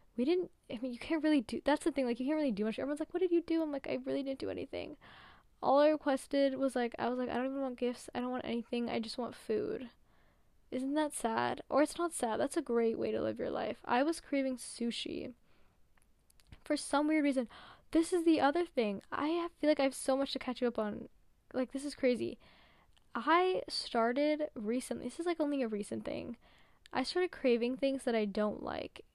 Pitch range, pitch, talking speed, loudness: 240-300 Hz, 265 Hz, 235 wpm, -35 LUFS